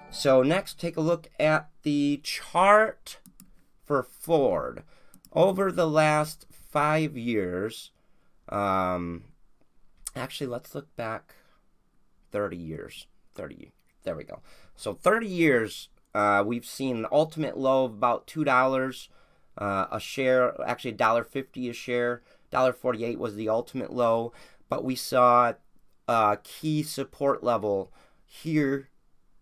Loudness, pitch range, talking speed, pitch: -26 LUFS, 120-150 Hz, 125 wpm, 130 Hz